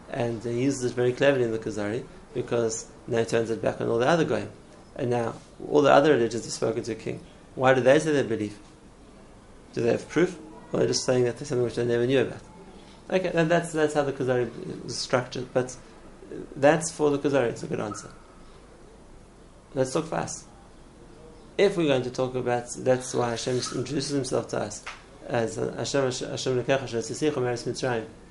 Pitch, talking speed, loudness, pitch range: 125 Hz, 200 wpm, -26 LUFS, 120-140 Hz